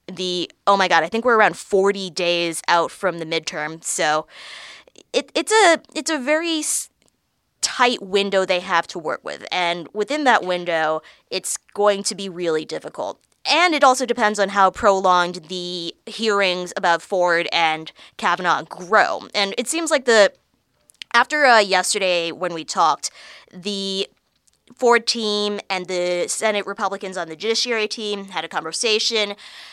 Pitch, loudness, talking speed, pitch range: 195 Hz, -20 LUFS, 155 wpm, 175-225 Hz